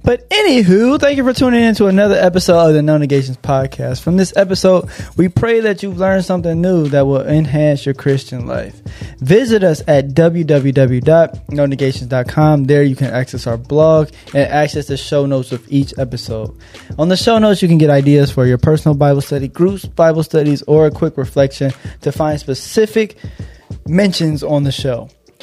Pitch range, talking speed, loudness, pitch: 135-180 Hz, 180 wpm, -13 LUFS, 150 Hz